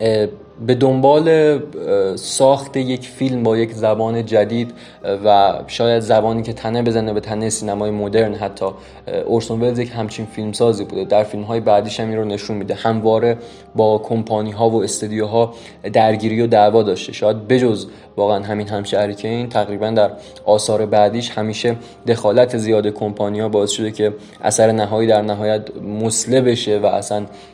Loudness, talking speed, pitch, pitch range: -17 LUFS, 160 wpm, 110 Hz, 105-115 Hz